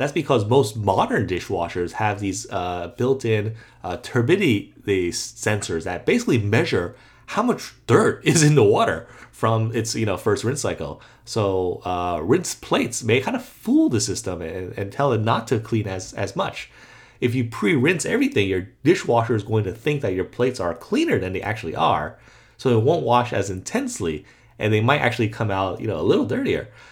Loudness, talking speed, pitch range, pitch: -22 LUFS, 190 wpm, 95-125 Hz, 110 Hz